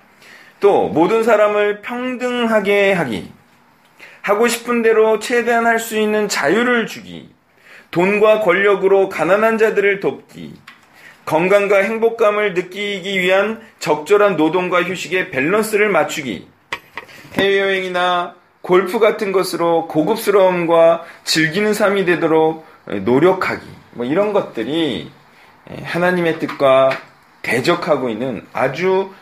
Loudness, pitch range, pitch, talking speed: -16 LUFS, 175-215 Hz, 195 Hz, 255 characters per minute